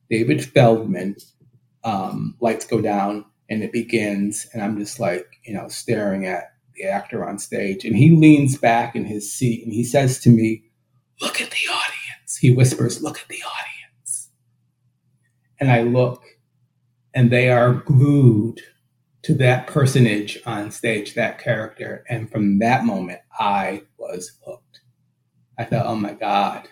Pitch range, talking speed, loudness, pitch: 110-130 Hz, 155 wpm, -19 LUFS, 120 Hz